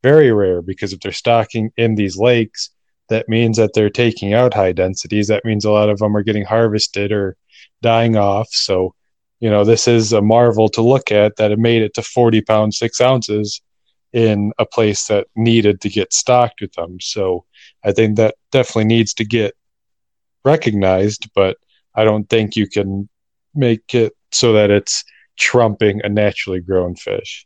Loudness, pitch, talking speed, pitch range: -15 LUFS, 110 Hz, 180 wpm, 105-115 Hz